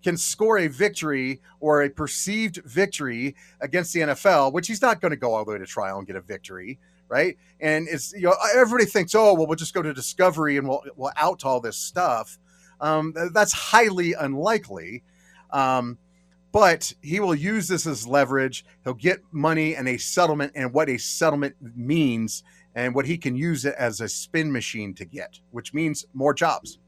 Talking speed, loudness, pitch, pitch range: 195 wpm, -23 LUFS, 155 Hz, 130-180 Hz